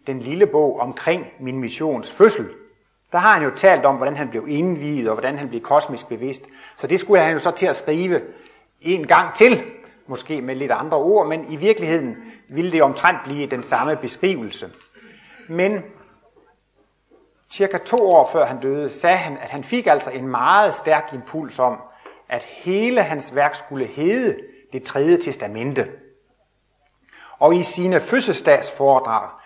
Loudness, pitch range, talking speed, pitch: -19 LUFS, 135-205 Hz, 165 wpm, 155 Hz